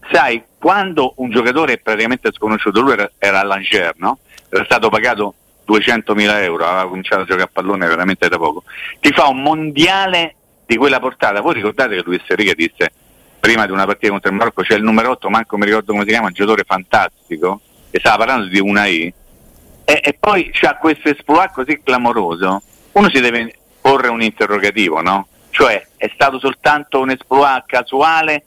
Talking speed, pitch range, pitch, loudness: 185 wpm, 105-150 Hz, 120 Hz, -14 LUFS